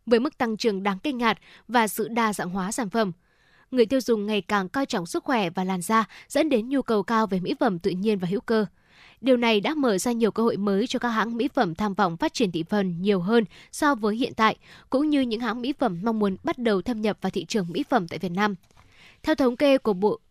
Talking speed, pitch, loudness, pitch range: 265 wpm, 220 Hz, -25 LUFS, 205-245 Hz